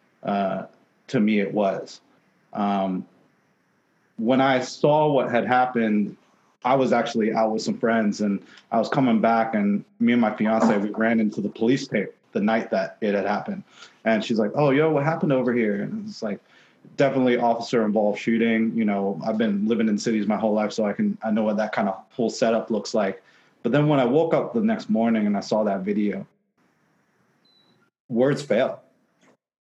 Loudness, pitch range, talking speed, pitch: -23 LUFS, 105-145 Hz, 195 wpm, 115 Hz